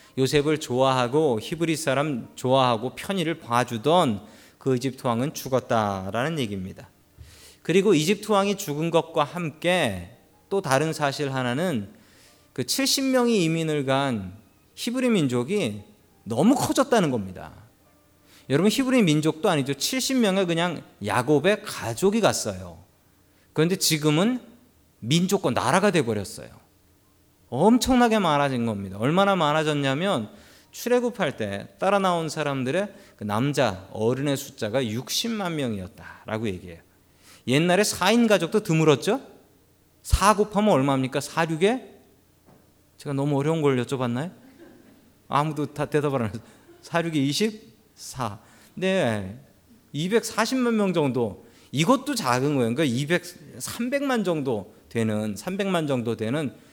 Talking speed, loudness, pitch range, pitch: 260 characters per minute, -24 LUFS, 115-195 Hz, 145 Hz